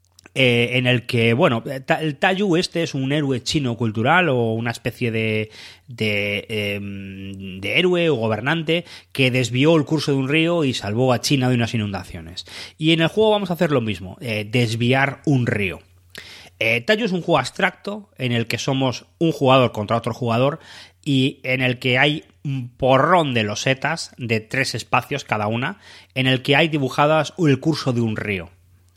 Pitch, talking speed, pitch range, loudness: 130 Hz, 185 wpm, 110-150 Hz, -20 LUFS